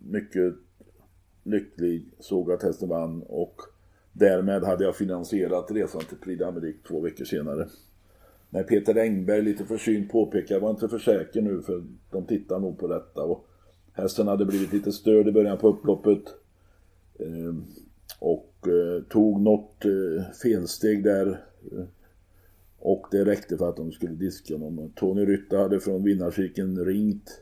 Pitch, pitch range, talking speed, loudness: 95 Hz, 90-105 Hz, 145 wpm, -26 LUFS